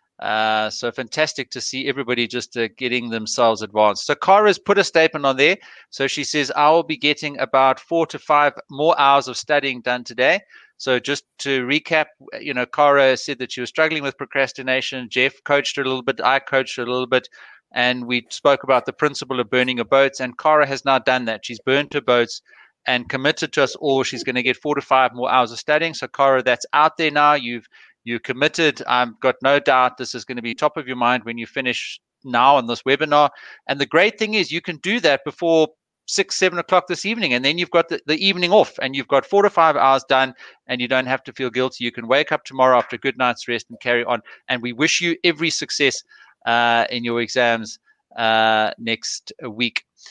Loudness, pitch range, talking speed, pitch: -19 LUFS, 125-150 Hz, 230 wpm, 135 Hz